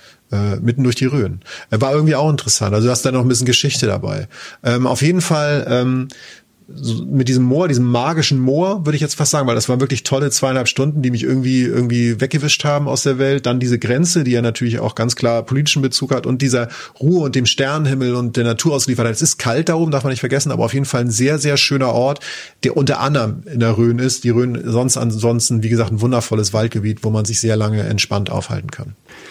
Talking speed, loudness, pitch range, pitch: 235 wpm, -16 LUFS, 115-140 Hz, 125 Hz